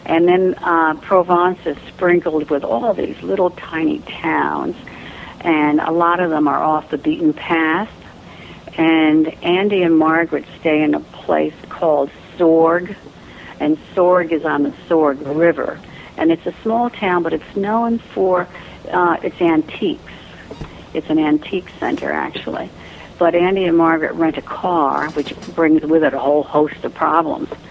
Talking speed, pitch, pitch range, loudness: 155 wpm, 165 Hz, 155-180 Hz, -17 LUFS